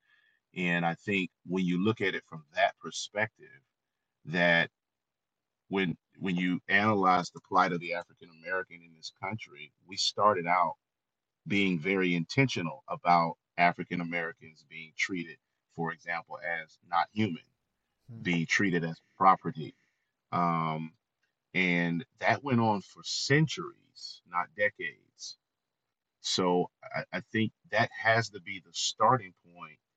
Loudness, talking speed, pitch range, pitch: -30 LUFS, 130 wpm, 85-110 Hz, 90 Hz